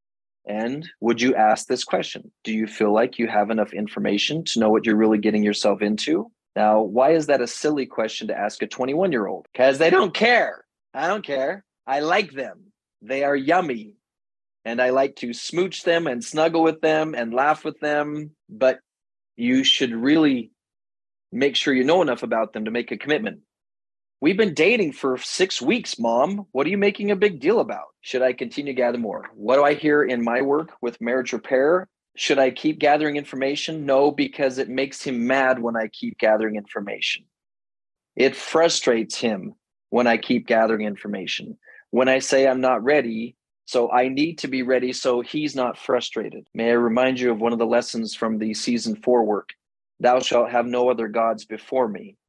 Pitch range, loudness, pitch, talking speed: 115-150 Hz, -21 LUFS, 125 Hz, 195 wpm